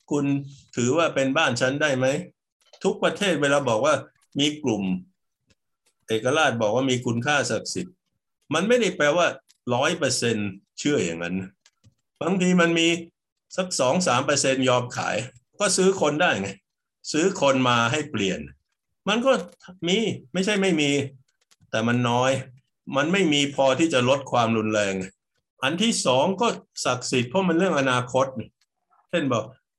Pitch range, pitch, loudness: 120-170 Hz, 140 Hz, -23 LUFS